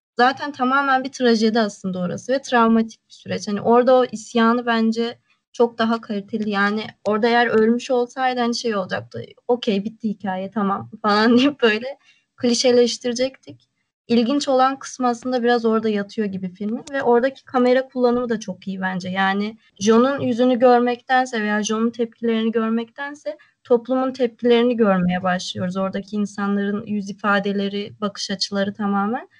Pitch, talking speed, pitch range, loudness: 230 Hz, 145 wpm, 205-245 Hz, -20 LUFS